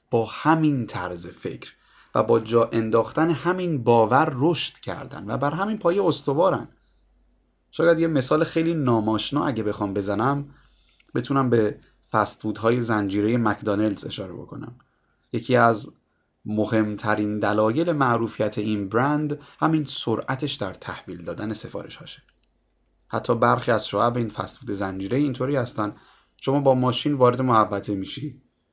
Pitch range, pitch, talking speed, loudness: 105-145 Hz, 120 Hz, 130 wpm, -23 LUFS